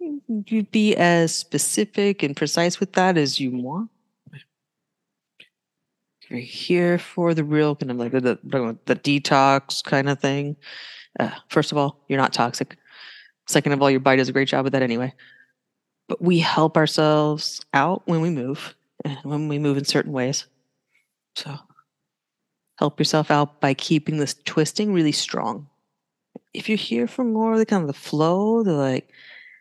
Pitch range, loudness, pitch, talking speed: 140-175 Hz, -21 LUFS, 150 Hz, 170 wpm